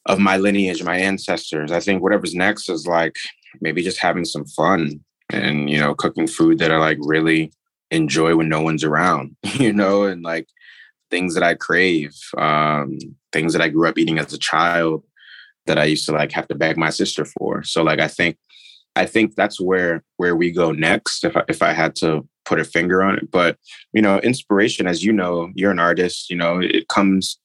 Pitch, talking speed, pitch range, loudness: 85 Hz, 210 wpm, 80-95 Hz, -18 LUFS